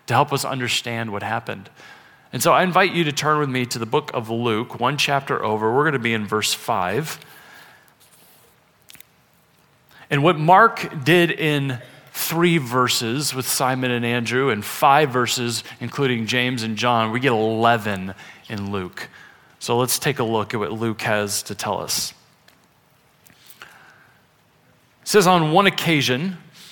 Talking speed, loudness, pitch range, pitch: 155 wpm, -20 LUFS, 115-150 Hz, 125 Hz